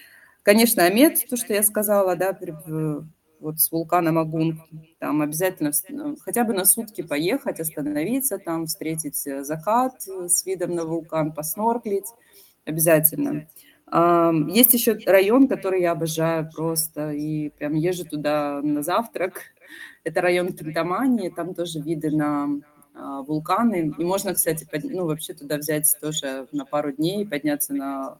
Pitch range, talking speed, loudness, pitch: 150-190 Hz, 135 wpm, -22 LUFS, 165 Hz